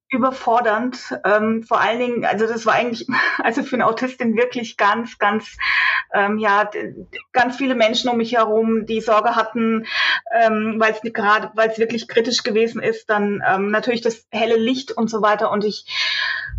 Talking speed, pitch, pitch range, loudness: 175 wpm, 225 Hz, 215-235 Hz, -19 LUFS